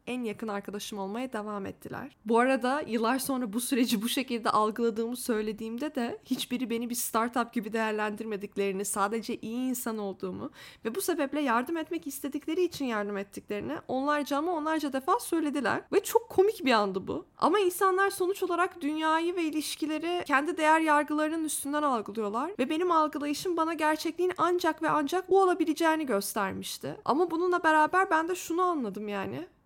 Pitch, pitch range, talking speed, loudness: 285 Hz, 230-325 Hz, 160 wpm, -29 LUFS